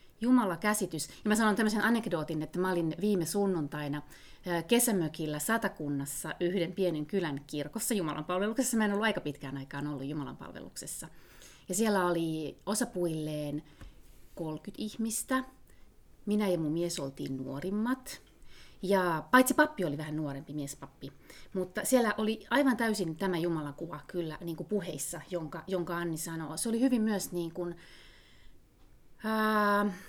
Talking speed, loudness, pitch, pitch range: 140 wpm, -32 LUFS, 175 Hz, 155-210 Hz